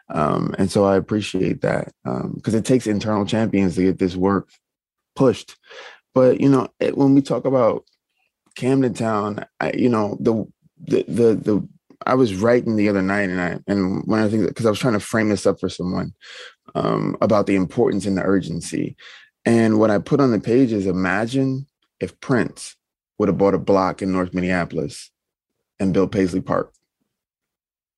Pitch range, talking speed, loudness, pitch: 95-115 Hz, 180 wpm, -20 LUFS, 105 Hz